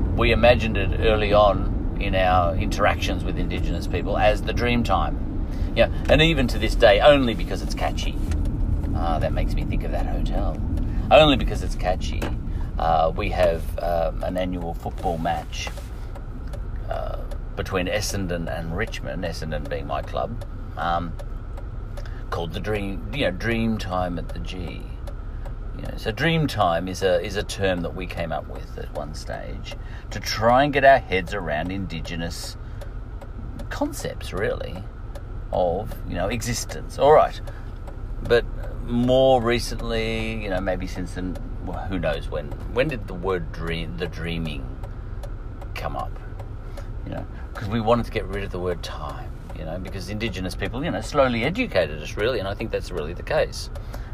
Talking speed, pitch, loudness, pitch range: 165 wpm, 95 Hz, -24 LUFS, 85-110 Hz